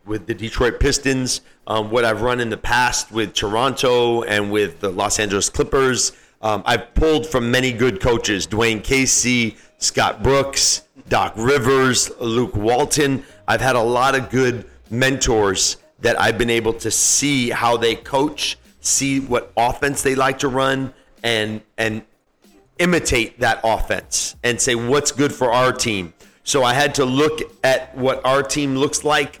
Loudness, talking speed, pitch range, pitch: -18 LUFS, 165 wpm, 115-135 Hz, 125 Hz